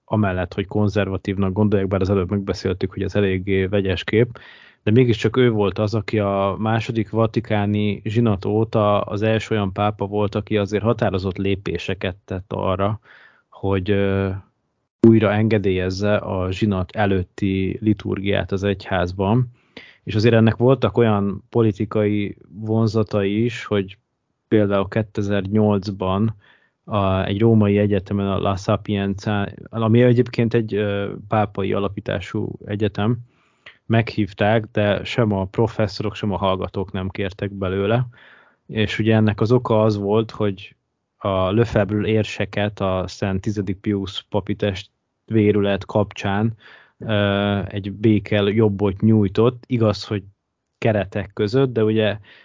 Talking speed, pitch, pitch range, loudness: 125 wpm, 105 Hz, 100-110 Hz, -20 LUFS